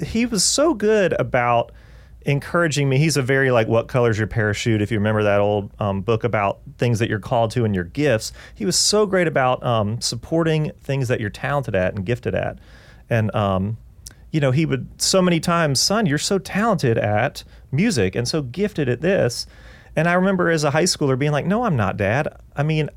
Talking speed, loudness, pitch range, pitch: 210 wpm, -20 LUFS, 115-165 Hz, 135 Hz